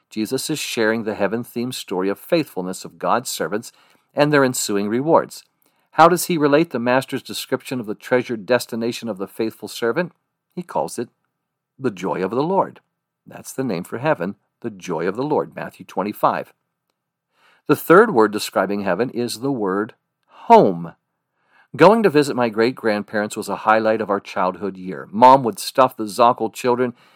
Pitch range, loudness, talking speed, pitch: 105-130 Hz, -19 LUFS, 175 wpm, 115 Hz